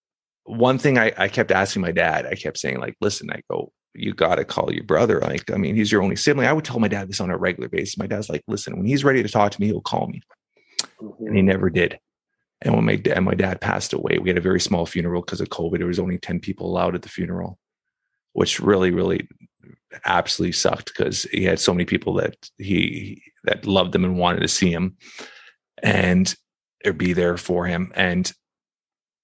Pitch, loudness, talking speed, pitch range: 95 Hz, -21 LUFS, 225 wpm, 90-110 Hz